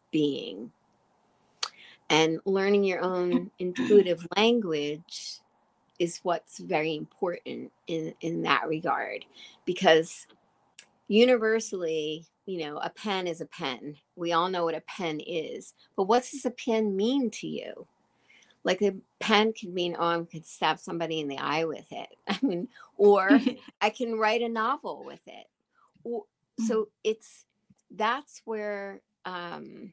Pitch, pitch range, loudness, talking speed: 190 Hz, 165-220 Hz, -28 LUFS, 140 wpm